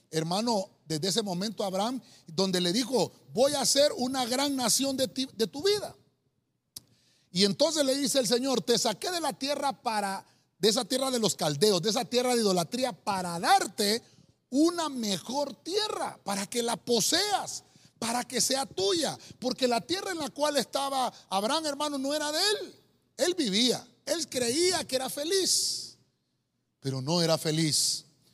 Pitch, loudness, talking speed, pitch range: 245 Hz, -28 LUFS, 165 wpm, 200-280 Hz